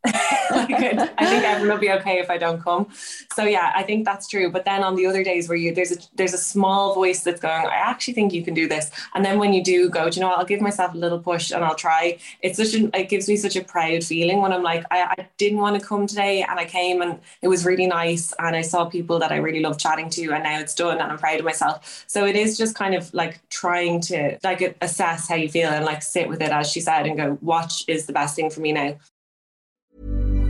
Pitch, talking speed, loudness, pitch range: 175 Hz, 275 wpm, -21 LUFS, 165-195 Hz